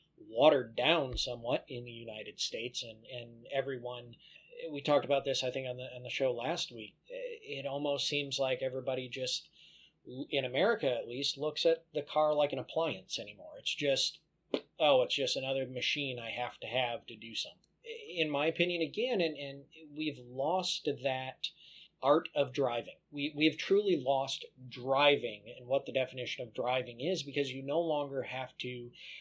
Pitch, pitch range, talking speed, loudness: 135 Hz, 125-150 Hz, 175 wpm, -34 LUFS